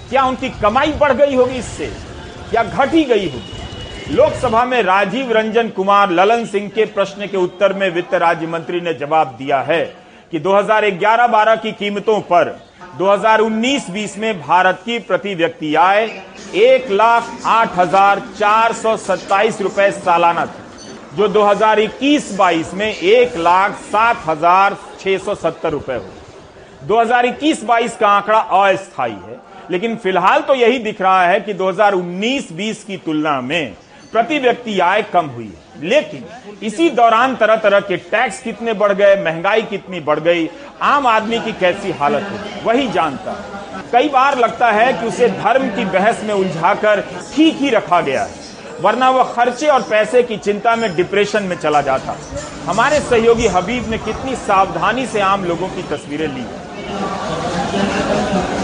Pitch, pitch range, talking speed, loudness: 205 Hz, 185-230 Hz, 155 wpm, -15 LUFS